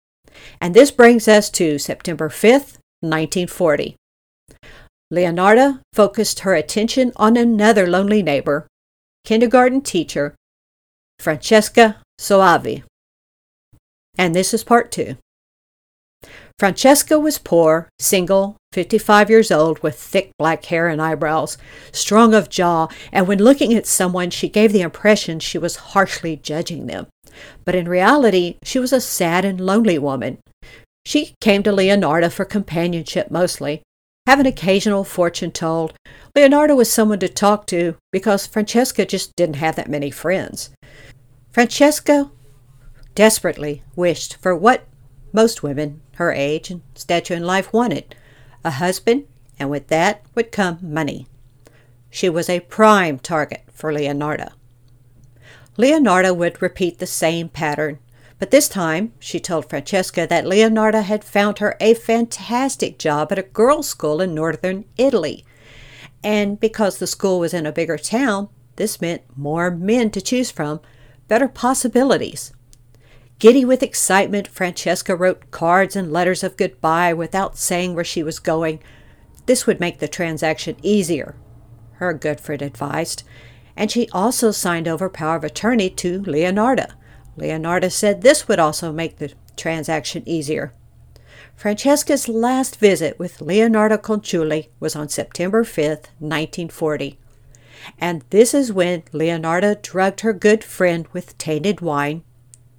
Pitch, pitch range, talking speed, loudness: 175 Hz, 150-210 Hz, 135 wpm, -17 LUFS